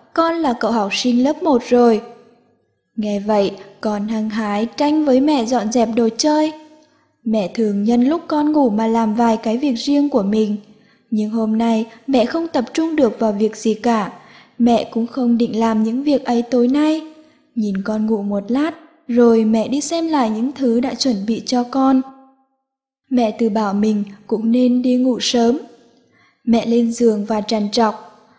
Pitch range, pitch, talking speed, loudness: 220-270 Hz, 235 Hz, 185 wpm, -17 LUFS